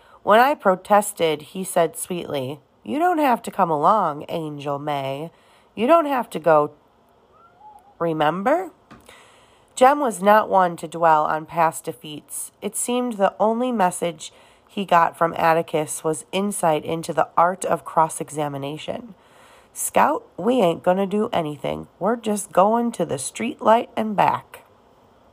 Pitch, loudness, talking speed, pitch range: 180 Hz, -21 LUFS, 145 wpm, 160-225 Hz